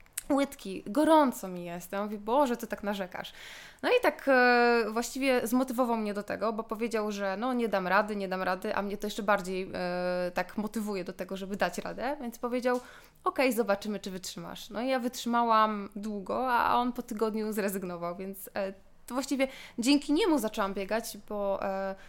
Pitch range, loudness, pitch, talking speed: 195-245 Hz, -30 LUFS, 215 Hz, 185 wpm